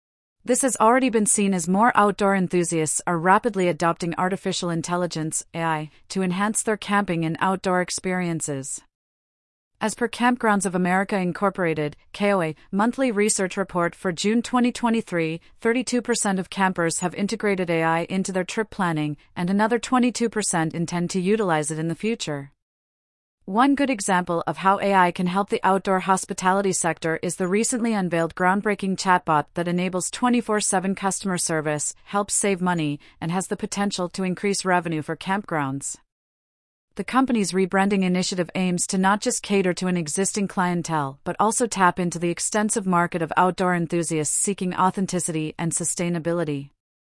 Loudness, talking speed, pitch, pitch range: -23 LUFS, 150 wpm, 185 Hz, 170-205 Hz